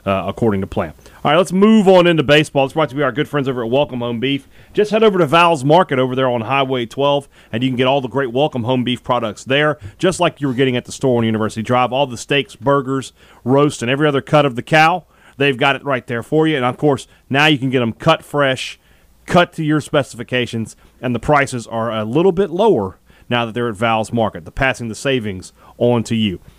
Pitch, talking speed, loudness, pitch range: 130 Hz, 250 wpm, -16 LUFS, 115-150 Hz